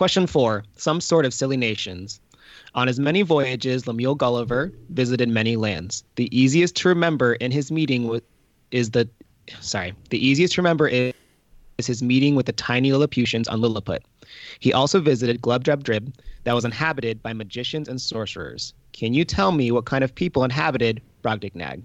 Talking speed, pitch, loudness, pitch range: 170 wpm, 125 Hz, -22 LUFS, 115-140 Hz